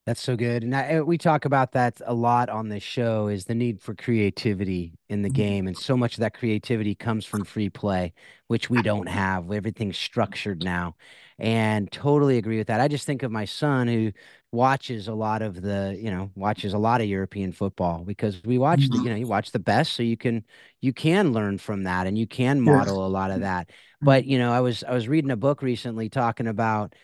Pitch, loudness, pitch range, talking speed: 110 Hz, -25 LUFS, 100-125 Hz, 230 wpm